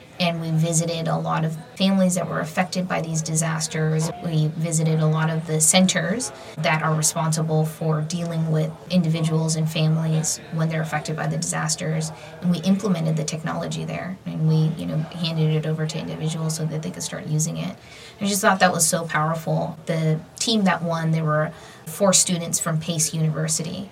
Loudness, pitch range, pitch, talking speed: -22 LUFS, 155-170 Hz, 160 Hz, 190 wpm